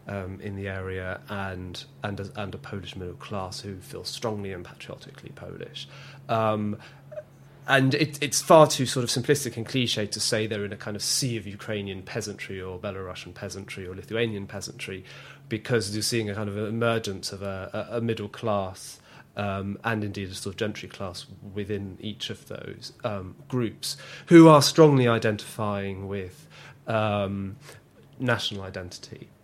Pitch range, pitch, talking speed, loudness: 100-125 Hz, 105 Hz, 165 wpm, -26 LUFS